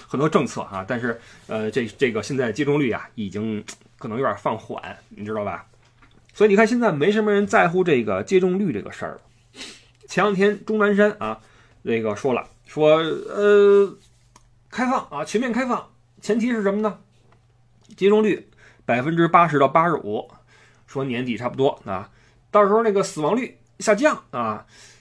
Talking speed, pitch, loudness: 260 characters per minute, 155 Hz, -21 LUFS